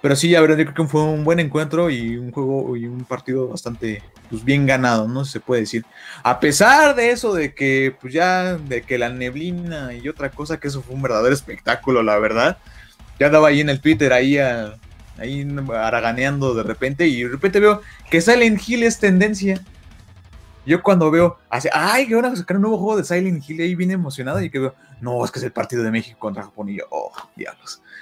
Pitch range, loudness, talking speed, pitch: 120-170 Hz, -18 LUFS, 225 wpm, 140 Hz